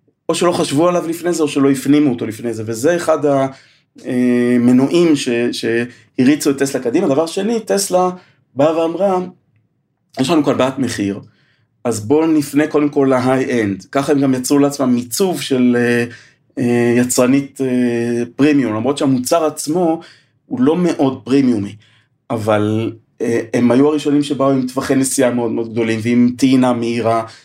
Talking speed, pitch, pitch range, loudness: 145 wpm, 135 Hz, 120-150 Hz, -15 LUFS